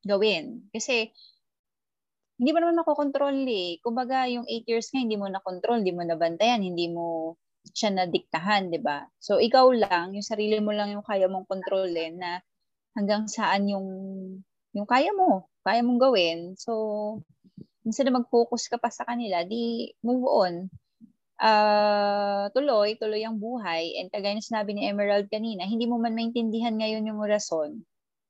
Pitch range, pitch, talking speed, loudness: 190-235 Hz, 215 Hz, 165 wpm, -26 LUFS